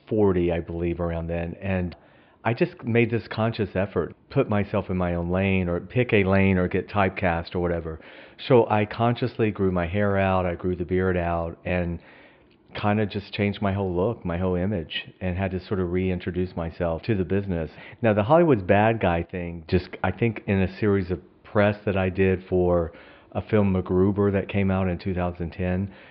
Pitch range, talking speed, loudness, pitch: 90-105 Hz, 200 wpm, -25 LUFS, 95 Hz